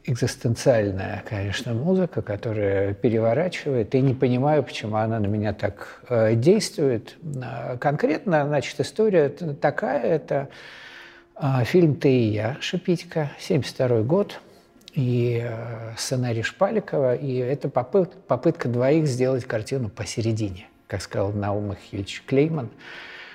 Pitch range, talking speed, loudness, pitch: 115-150 Hz, 110 wpm, -24 LUFS, 125 Hz